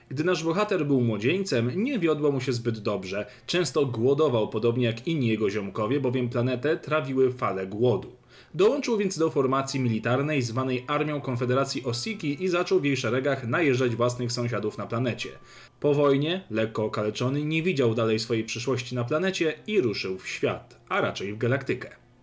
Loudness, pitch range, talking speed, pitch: -26 LUFS, 120-150 Hz, 165 wpm, 130 Hz